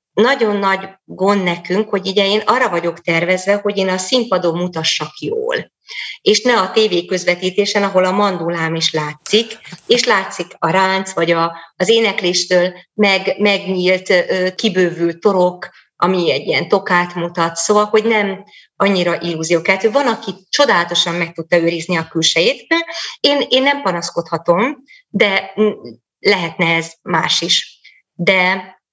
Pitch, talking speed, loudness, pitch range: 185 Hz, 135 wpm, -15 LUFS, 170-210 Hz